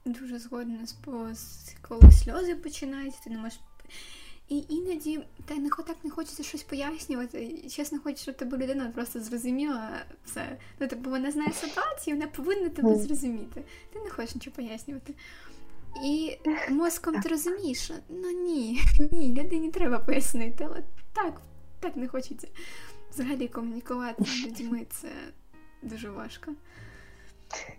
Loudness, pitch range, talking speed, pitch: -29 LUFS, 245-310 Hz, 125 wpm, 280 Hz